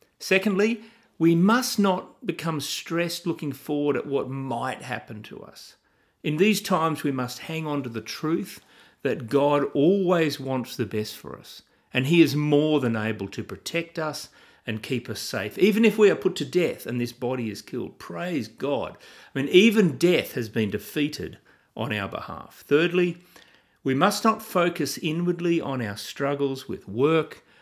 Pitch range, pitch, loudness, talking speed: 130-180 Hz, 155 Hz, -25 LUFS, 175 wpm